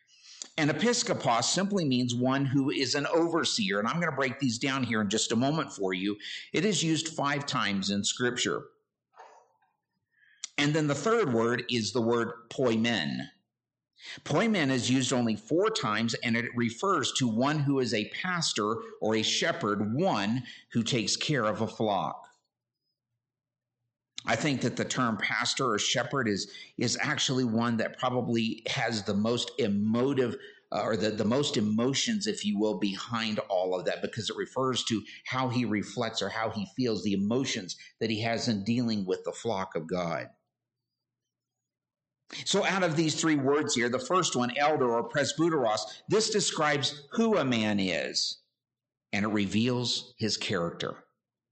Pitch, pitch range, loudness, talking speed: 125 Hz, 115-145 Hz, -29 LUFS, 165 wpm